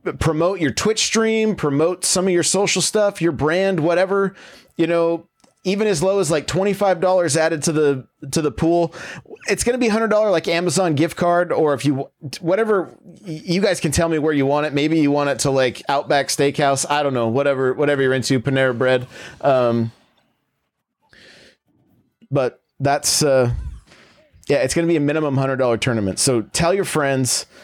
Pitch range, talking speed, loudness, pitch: 140-180 Hz, 175 wpm, -18 LUFS, 155 Hz